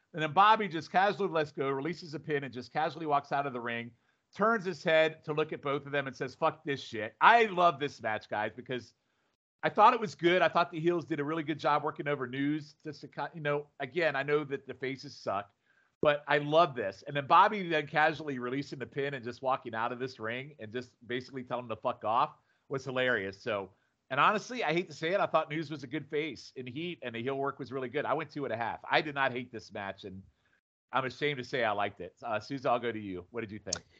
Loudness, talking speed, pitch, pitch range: -31 LUFS, 265 wpm, 140 Hz, 125-160 Hz